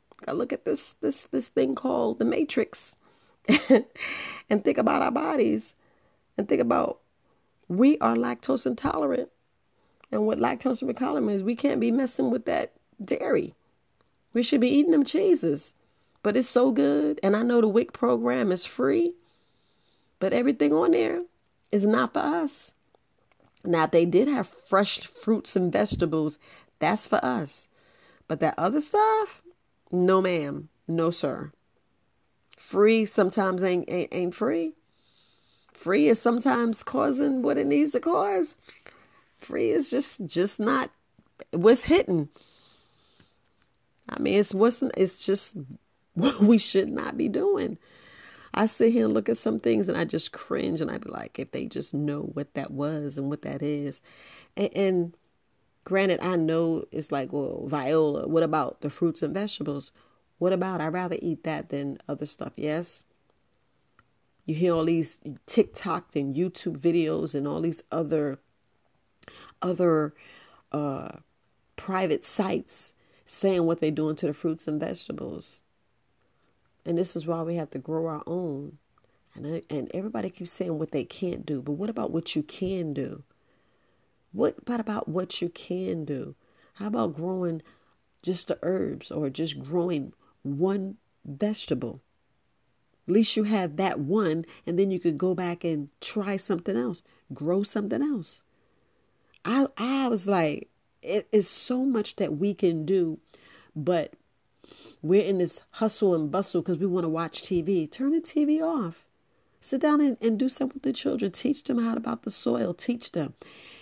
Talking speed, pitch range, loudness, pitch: 160 wpm, 155-230 Hz, -26 LUFS, 180 Hz